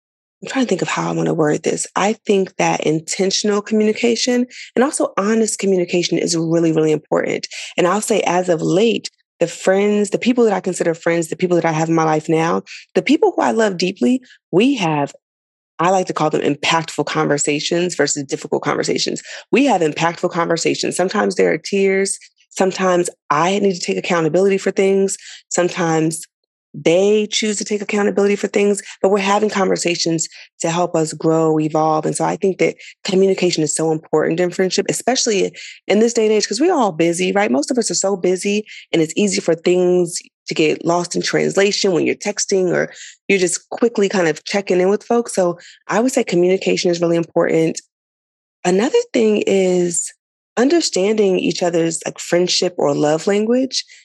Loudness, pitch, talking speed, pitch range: -17 LUFS, 185 Hz, 185 wpm, 165-205 Hz